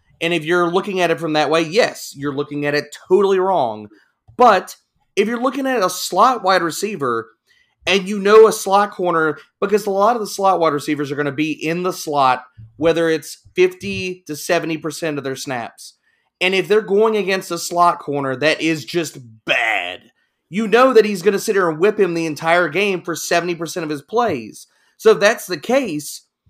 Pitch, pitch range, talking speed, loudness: 175 Hz, 155-200 Hz, 205 wpm, -17 LUFS